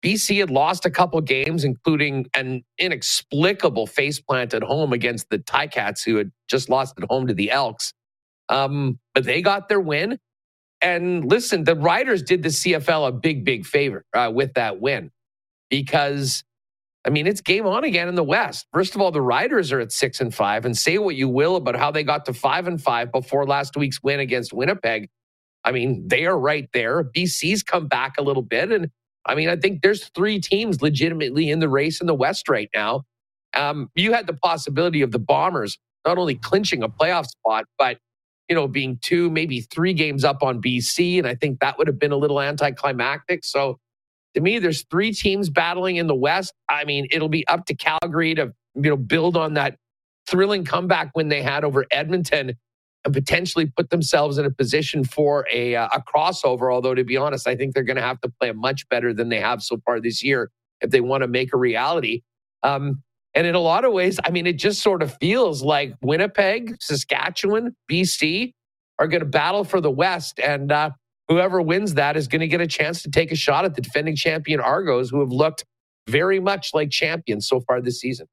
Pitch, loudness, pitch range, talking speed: 150 Hz, -21 LUFS, 130-175 Hz, 210 wpm